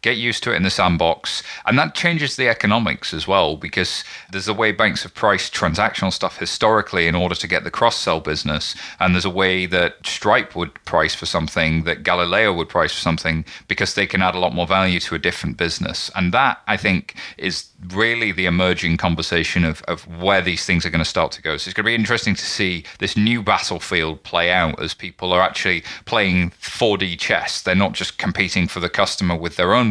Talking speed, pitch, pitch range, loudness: 220 wpm, 90 Hz, 85-100 Hz, -19 LUFS